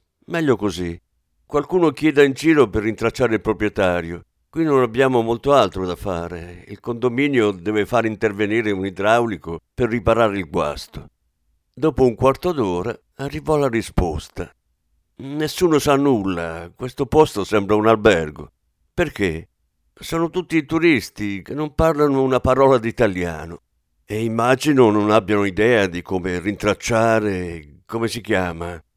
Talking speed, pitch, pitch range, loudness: 135 wpm, 110 Hz, 90-135 Hz, -19 LUFS